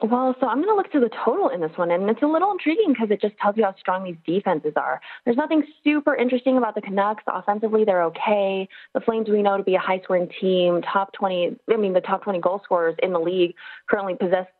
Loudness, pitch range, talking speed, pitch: -22 LUFS, 185-250 Hz, 250 wpm, 205 Hz